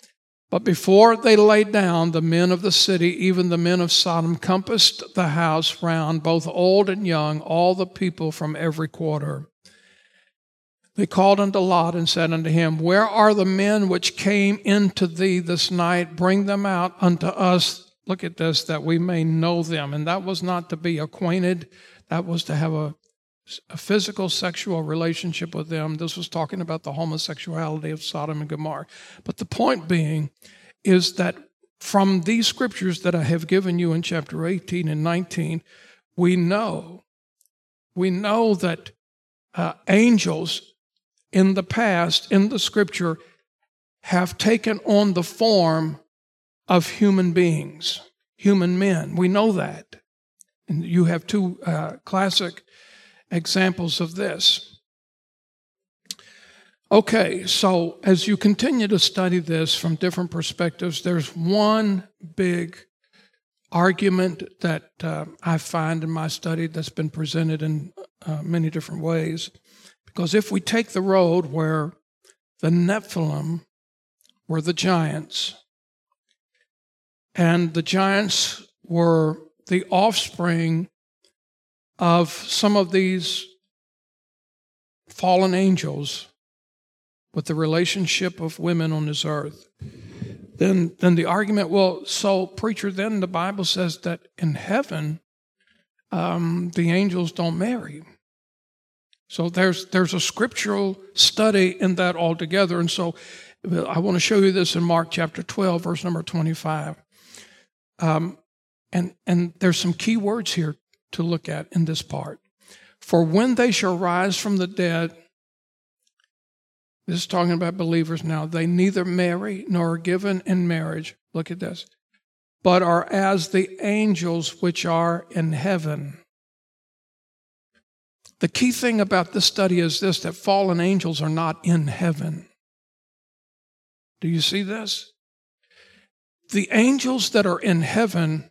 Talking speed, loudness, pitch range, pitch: 140 wpm, -21 LUFS, 165-195 Hz, 175 Hz